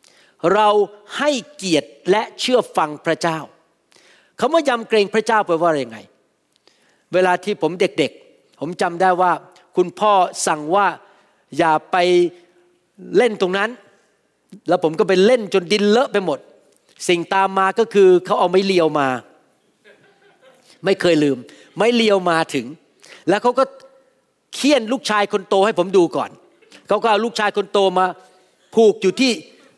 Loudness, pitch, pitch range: -18 LUFS, 195 Hz, 175-215 Hz